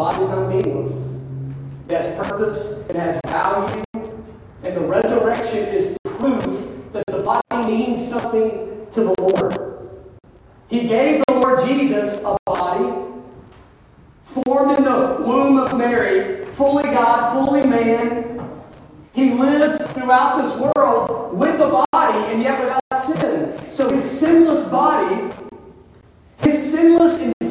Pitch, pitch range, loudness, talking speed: 245 Hz, 210-275 Hz, -18 LUFS, 125 wpm